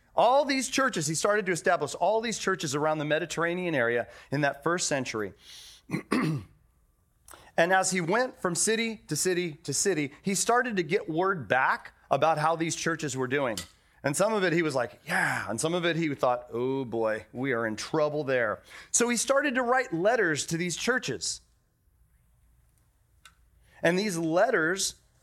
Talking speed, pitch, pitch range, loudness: 175 wpm, 165 Hz, 140-195 Hz, -27 LUFS